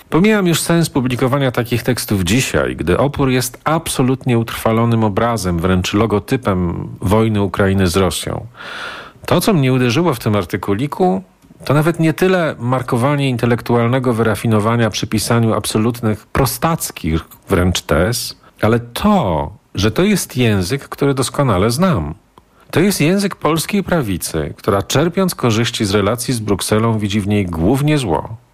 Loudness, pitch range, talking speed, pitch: -16 LUFS, 105-145 Hz, 135 wpm, 120 Hz